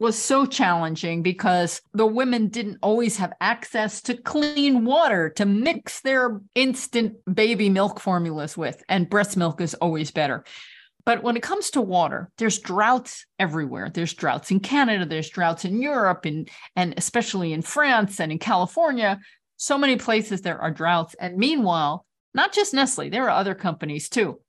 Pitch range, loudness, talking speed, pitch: 175-245 Hz, -23 LUFS, 165 wpm, 205 Hz